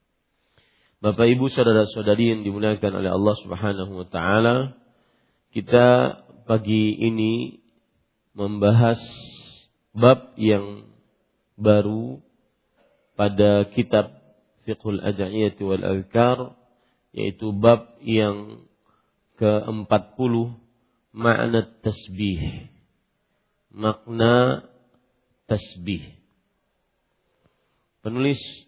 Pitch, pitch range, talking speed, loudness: 110 Hz, 105-120 Hz, 70 wpm, -22 LUFS